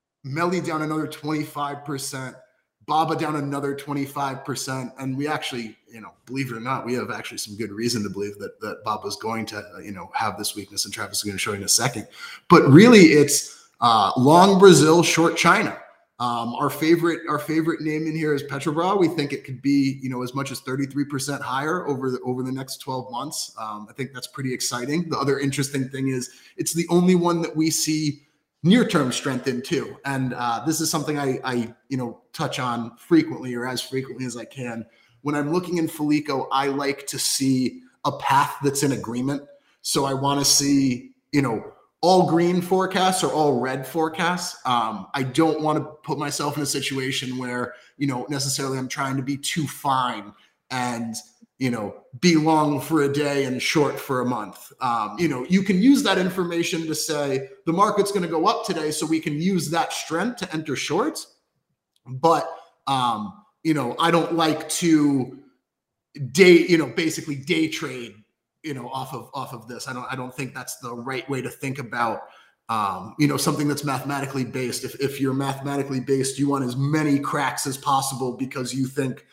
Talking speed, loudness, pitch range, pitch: 205 wpm, -22 LUFS, 130-160 Hz, 140 Hz